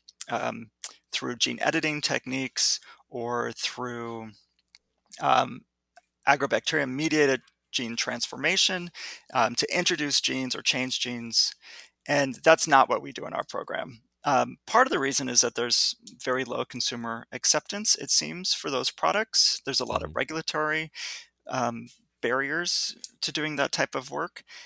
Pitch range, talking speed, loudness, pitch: 120-155 Hz, 140 wpm, -26 LUFS, 130 Hz